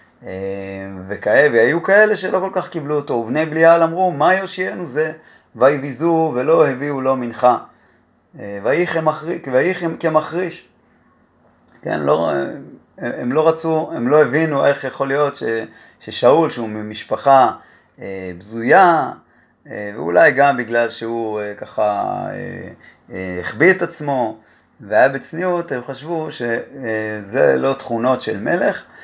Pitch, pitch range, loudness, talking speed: 140 Hz, 115-165 Hz, -17 LUFS, 110 wpm